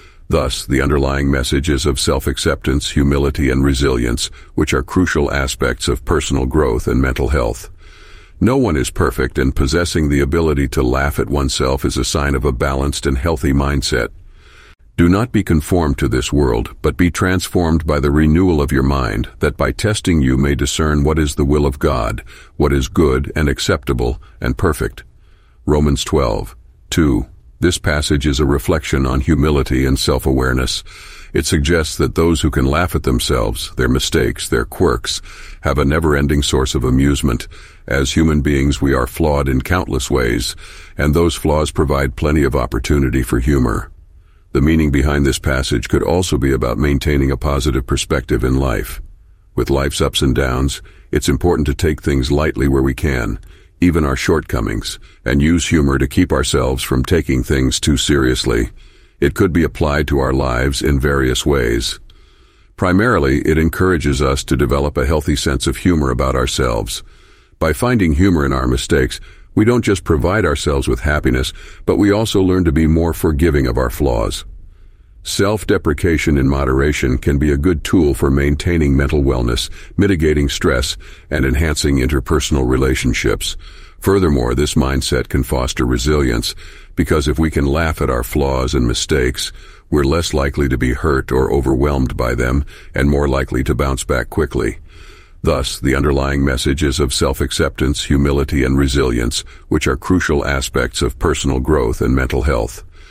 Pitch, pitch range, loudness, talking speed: 70 Hz, 65-80 Hz, -16 LUFS, 165 wpm